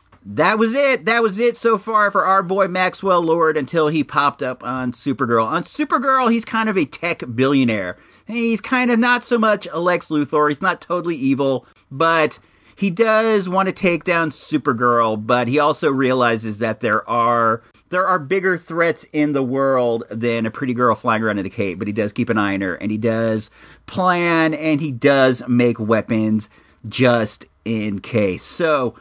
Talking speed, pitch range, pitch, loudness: 190 wpm, 115-185 Hz, 145 Hz, -18 LUFS